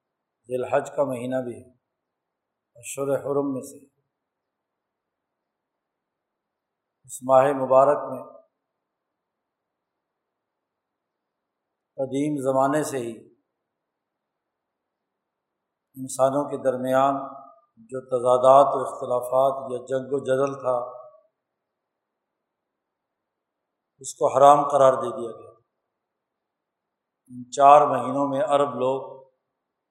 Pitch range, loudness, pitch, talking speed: 130-140 Hz, -22 LUFS, 135 Hz, 85 wpm